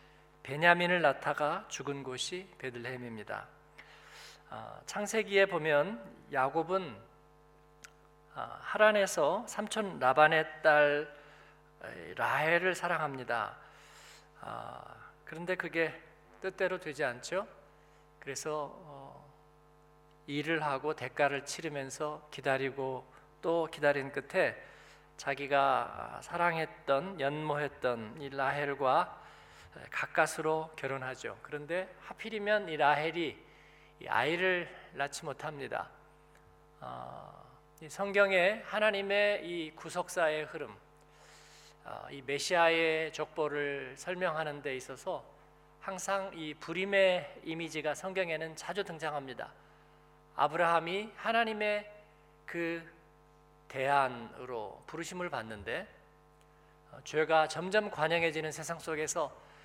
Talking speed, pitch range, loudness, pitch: 220 characters per minute, 145-180 Hz, -33 LUFS, 155 Hz